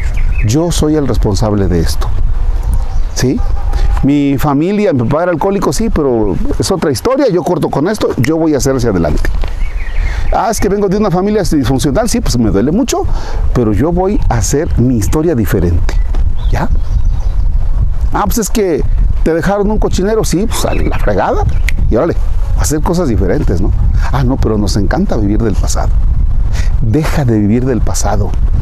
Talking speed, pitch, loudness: 170 wpm, 105 Hz, -13 LUFS